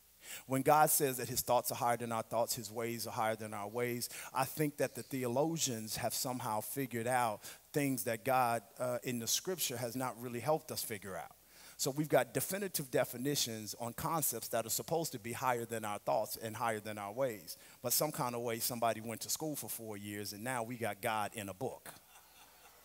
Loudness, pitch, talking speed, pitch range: -36 LUFS, 120 Hz, 215 wpm, 115-135 Hz